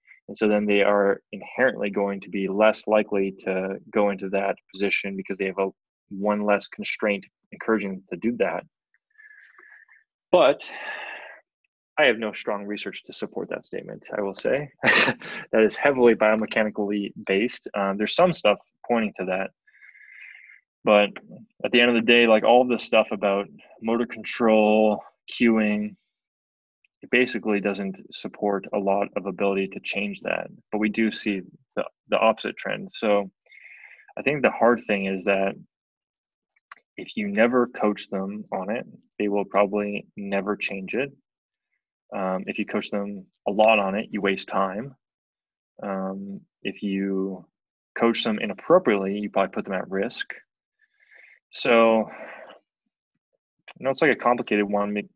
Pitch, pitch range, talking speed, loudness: 105 Hz, 100-115 Hz, 155 wpm, -24 LUFS